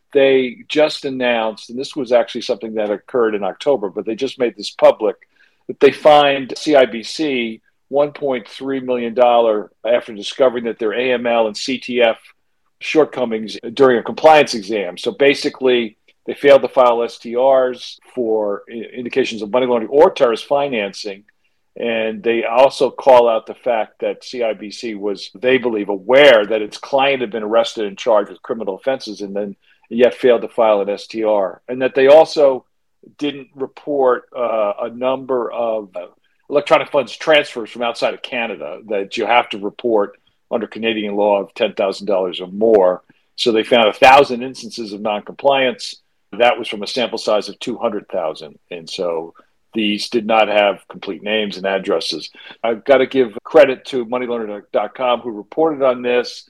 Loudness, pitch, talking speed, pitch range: -16 LUFS, 120 Hz, 155 wpm, 110-135 Hz